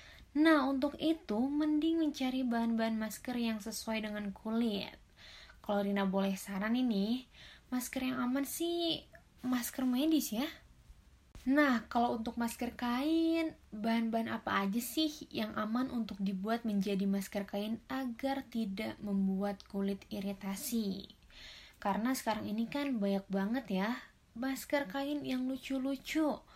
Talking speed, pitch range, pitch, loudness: 125 wpm, 210-270 Hz, 235 Hz, -35 LUFS